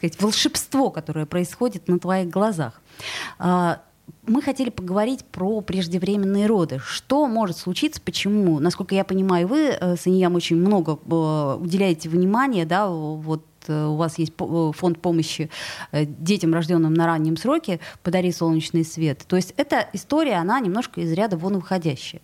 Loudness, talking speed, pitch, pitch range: -22 LUFS, 135 wpm, 180 Hz, 165-200 Hz